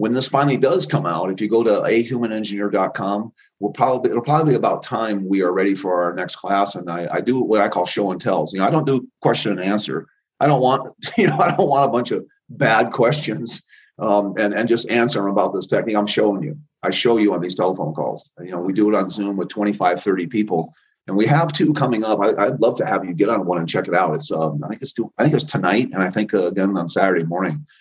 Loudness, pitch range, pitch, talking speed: -19 LUFS, 95-125 Hz, 105 Hz, 265 wpm